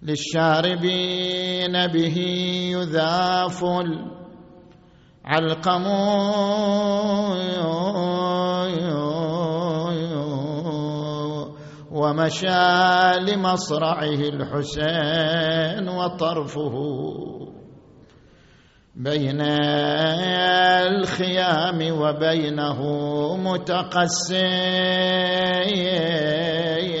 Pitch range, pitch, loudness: 150-180 Hz, 170 Hz, -22 LUFS